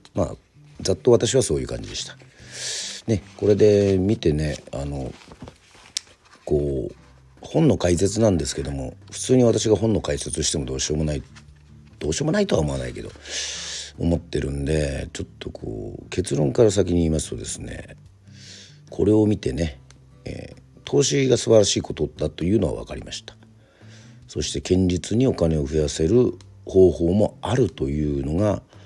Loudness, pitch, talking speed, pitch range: -22 LUFS, 95 Hz, 320 characters per minute, 75-110 Hz